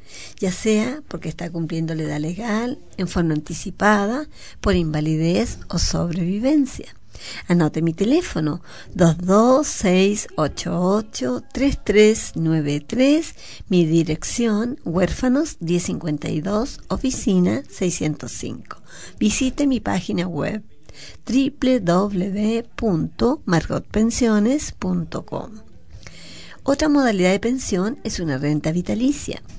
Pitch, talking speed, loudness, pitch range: 195 Hz, 80 wpm, -21 LUFS, 165-235 Hz